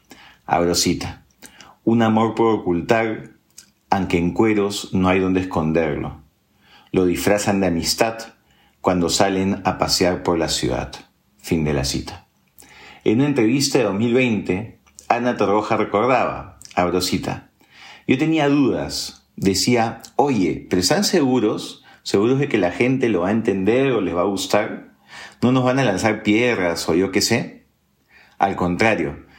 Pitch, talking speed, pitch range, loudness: 100 Hz, 145 wpm, 90-115 Hz, -19 LUFS